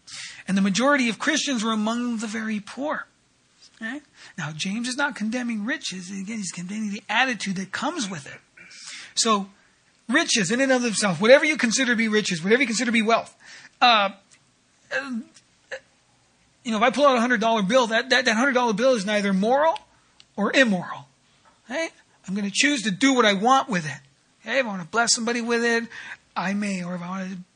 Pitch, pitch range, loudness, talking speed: 230 Hz, 200-255 Hz, -22 LUFS, 205 wpm